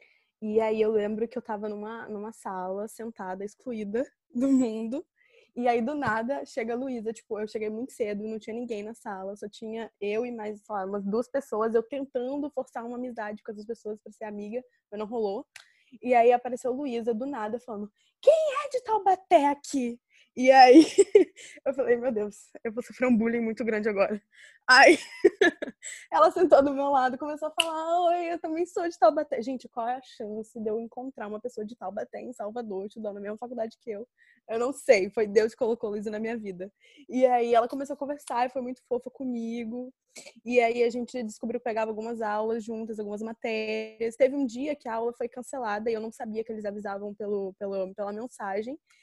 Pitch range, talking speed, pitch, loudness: 215-265 Hz, 210 wpm, 235 Hz, -27 LUFS